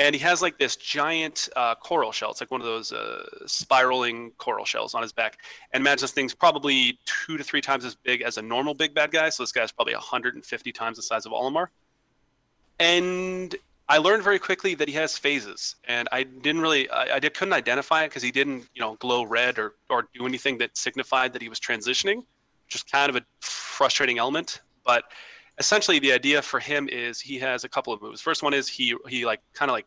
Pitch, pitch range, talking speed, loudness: 140 Hz, 125-160 Hz, 225 wpm, -24 LUFS